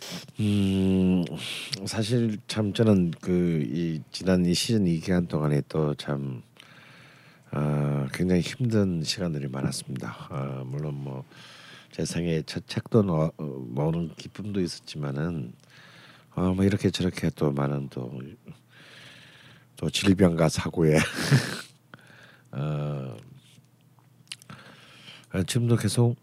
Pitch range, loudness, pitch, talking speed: 75-105 Hz, -27 LUFS, 85 Hz, 190 characters per minute